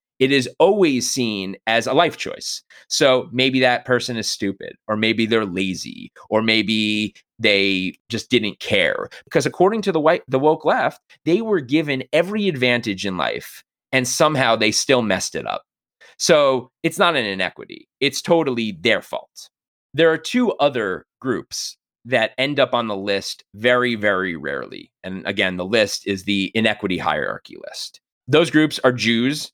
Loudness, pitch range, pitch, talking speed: -19 LUFS, 105-145 Hz, 120 Hz, 165 wpm